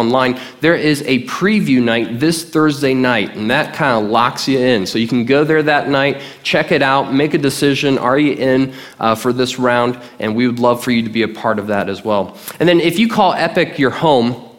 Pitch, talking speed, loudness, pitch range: 130 Hz, 240 wpm, -15 LUFS, 120-150 Hz